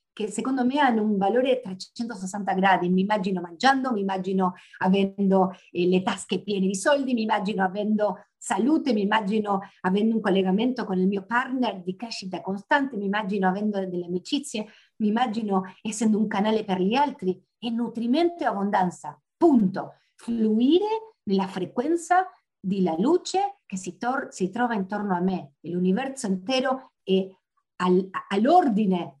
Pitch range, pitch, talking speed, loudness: 190-245 Hz, 205 Hz, 150 wpm, -25 LUFS